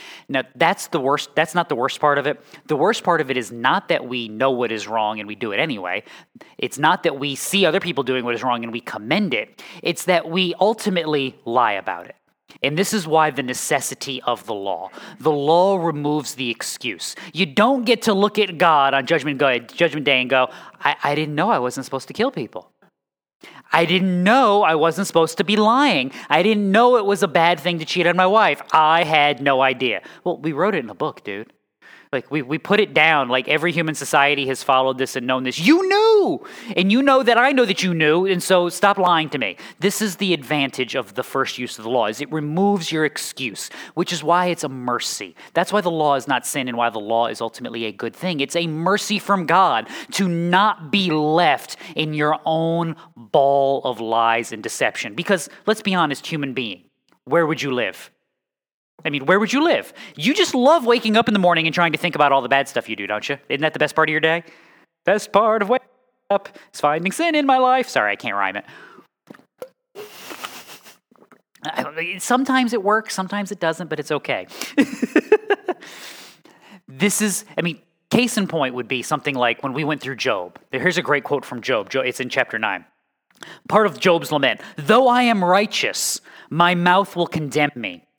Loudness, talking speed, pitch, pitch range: -19 LUFS, 215 wpm, 165 Hz, 140-200 Hz